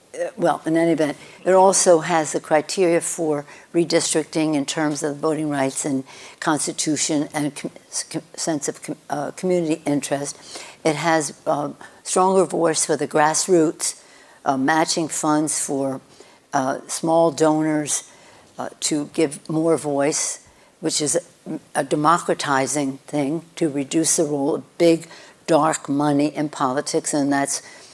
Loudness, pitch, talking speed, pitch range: -21 LUFS, 155 Hz, 140 wpm, 145-165 Hz